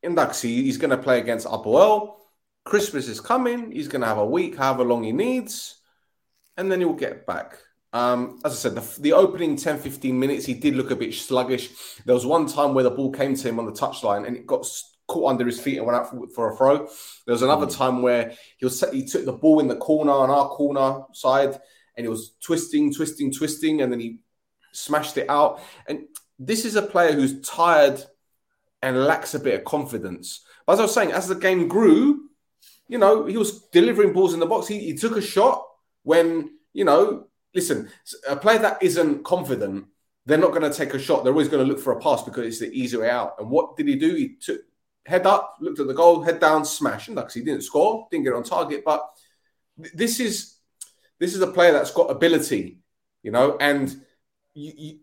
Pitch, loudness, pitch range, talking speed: 155 Hz, -22 LUFS, 135-210 Hz, 225 wpm